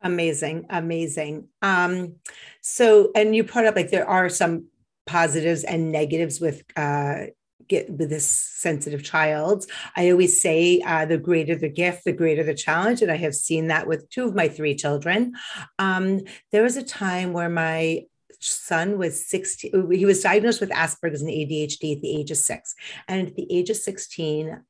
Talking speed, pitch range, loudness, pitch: 175 wpm, 155-195 Hz, -22 LUFS, 170 Hz